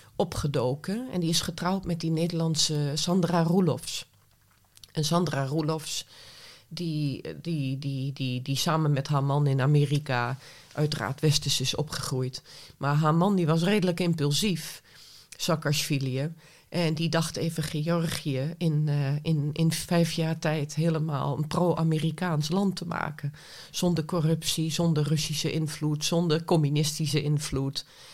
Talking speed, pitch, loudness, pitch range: 135 wpm, 155 Hz, -27 LUFS, 145-165 Hz